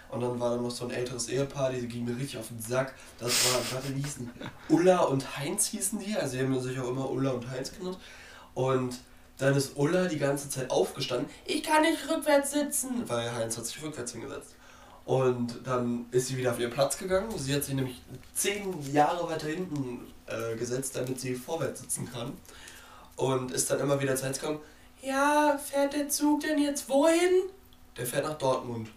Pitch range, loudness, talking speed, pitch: 125-185 Hz, -30 LUFS, 200 wpm, 135 Hz